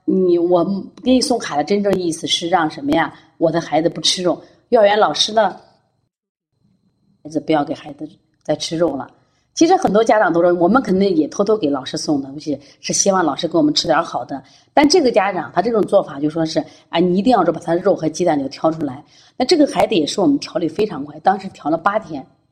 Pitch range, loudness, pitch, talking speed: 155-200 Hz, -17 LUFS, 170 Hz, 330 characters per minute